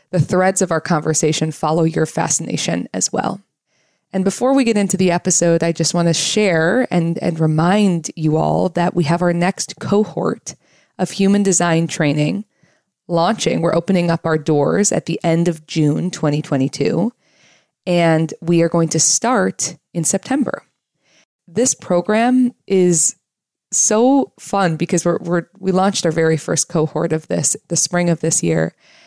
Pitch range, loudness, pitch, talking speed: 160-190 Hz, -17 LUFS, 170 Hz, 160 wpm